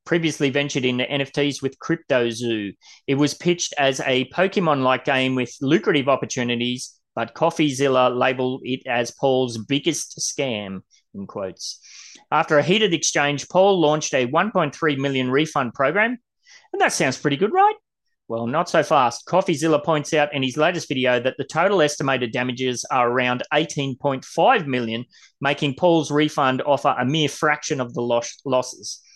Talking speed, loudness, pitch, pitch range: 150 wpm, -21 LUFS, 140 Hz, 125-160 Hz